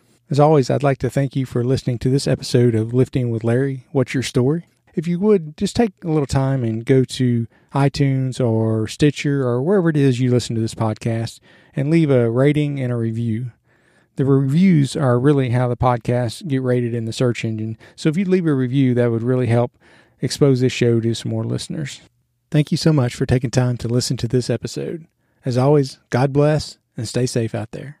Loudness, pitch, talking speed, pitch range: -19 LUFS, 130 Hz, 215 wpm, 120-145 Hz